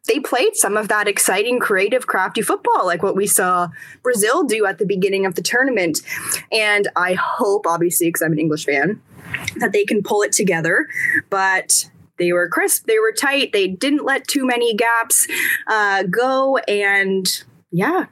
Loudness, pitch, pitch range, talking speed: -17 LUFS, 205 Hz, 180-250 Hz, 175 wpm